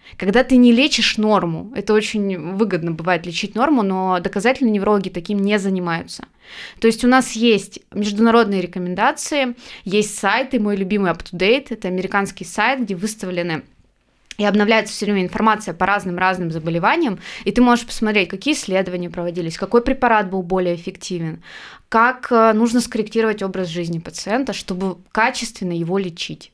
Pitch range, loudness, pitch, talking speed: 185-230 Hz, -18 LUFS, 205 Hz, 145 wpm